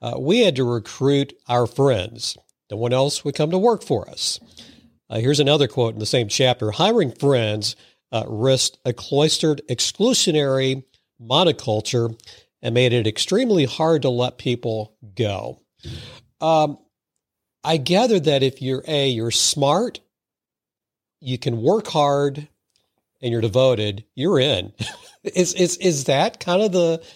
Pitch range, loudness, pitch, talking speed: 115-150 Hz, -20 LUFS, 130 Hz, 145 wpm